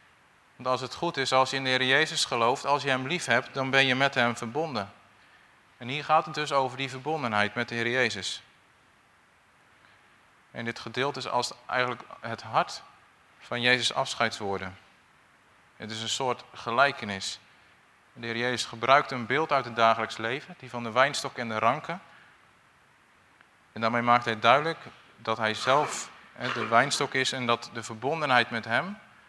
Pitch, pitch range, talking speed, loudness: 125 Hz, 115-135 Hz, 175 wpm, -27 LUFS